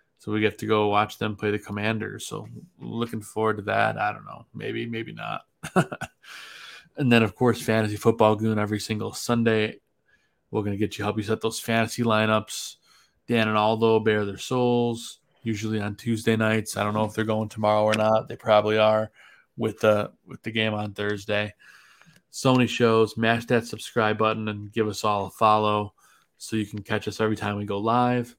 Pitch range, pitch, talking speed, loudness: 105-115 Hz, 110 Hz, 200 wpm, -25 LUFS